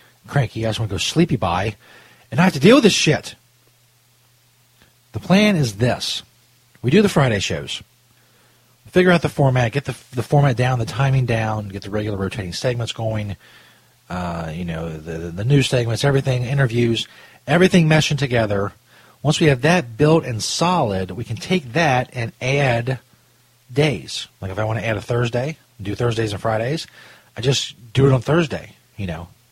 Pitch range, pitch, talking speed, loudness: 110-140 Hz, 120 Hz, 185 wpm, -19 LUFS